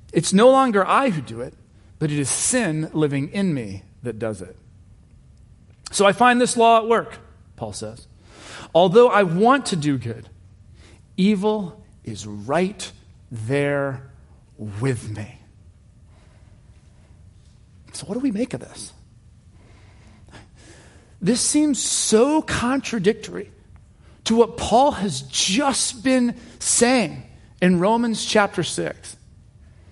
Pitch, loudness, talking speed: 135 Hz, -20 LUFS, 120 wpm